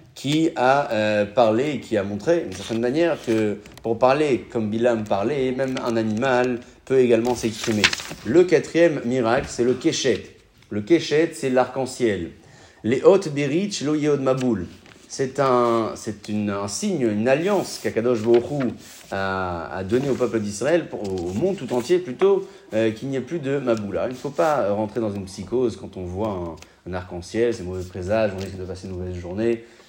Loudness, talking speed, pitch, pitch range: -22 LUFS, 185 wpm, 115 Hz, 105-135 Hz